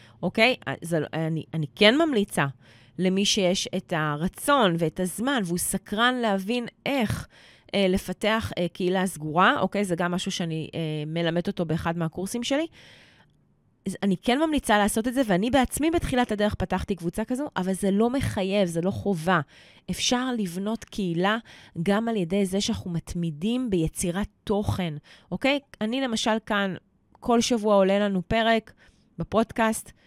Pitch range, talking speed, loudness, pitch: 175-225 Hz, 145 wpm, -25 LUFS, 195 Hz